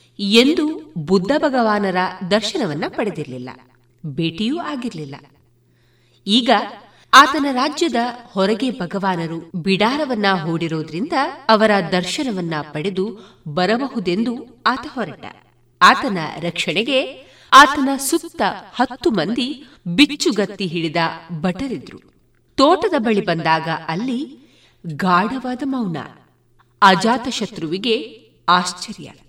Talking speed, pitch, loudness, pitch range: 80 wpm, 200 Hz, -18 LUFS, 170-255 Hz